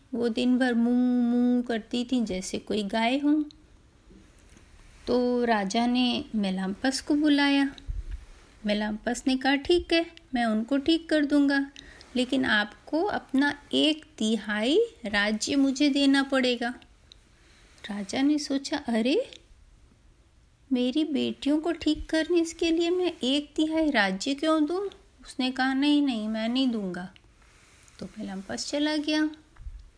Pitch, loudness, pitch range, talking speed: 265 Hz, -26 LUFS, 230-300 Hz, 130 wpm